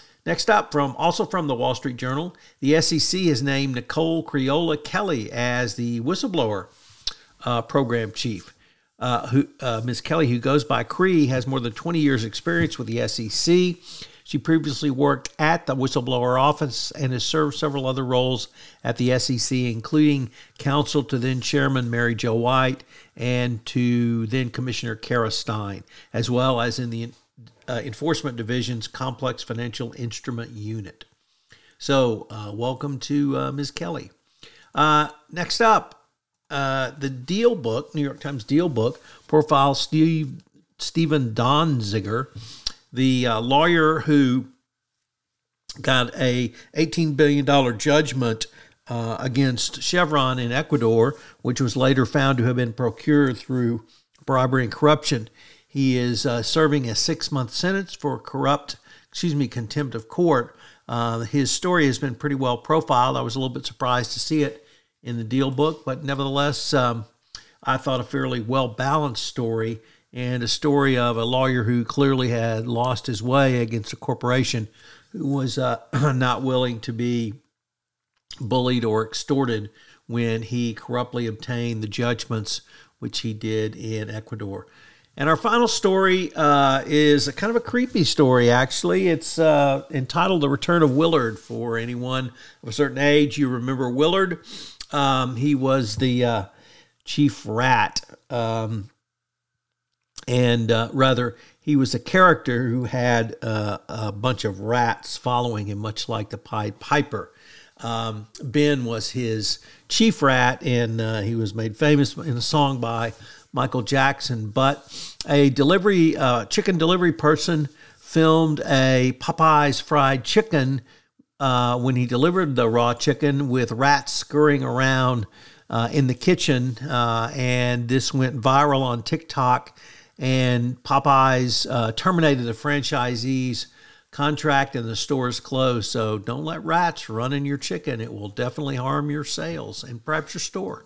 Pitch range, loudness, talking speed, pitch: 120-145 Hz, -22 LUFS, 150 wpm, 130 Hz